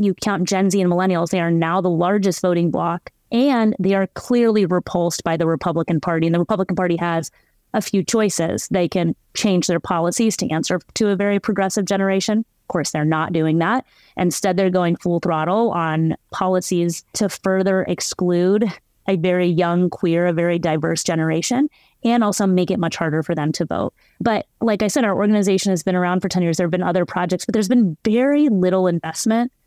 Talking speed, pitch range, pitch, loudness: 200 wpm, 170-200 Hz, 180 Hz, -19 LUFS